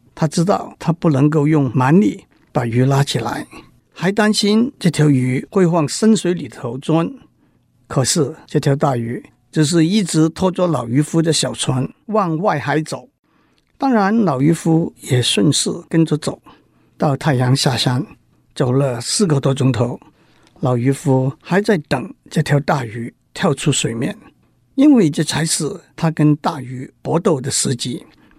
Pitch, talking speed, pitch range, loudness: 150 Hz, 215 characters per minute, 135-170 Hz, -17 LUFS